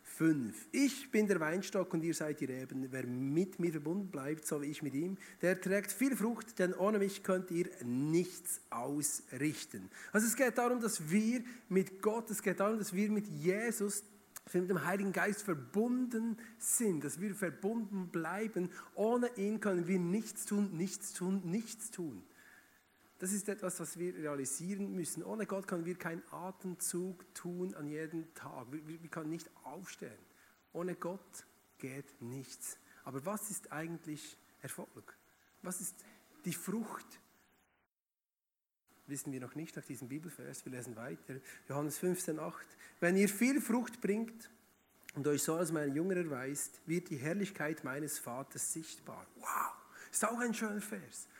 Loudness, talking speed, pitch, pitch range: -38 LUFS, 160 wpm, 180 Hz, 155-205 Hz